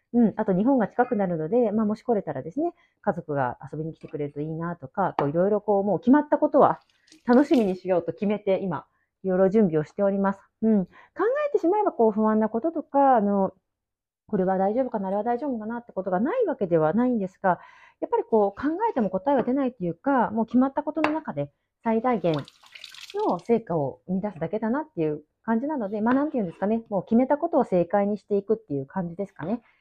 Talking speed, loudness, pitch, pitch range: 455 characters per minute, -25 LUFS, 215 Hz, 185-260 Hz